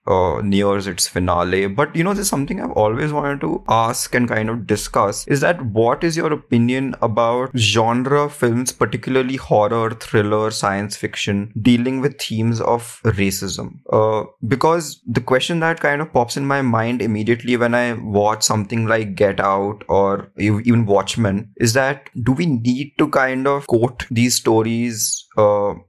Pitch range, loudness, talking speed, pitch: 105-130 Hz, -18 LUFS, 165 wpm, 120 Hz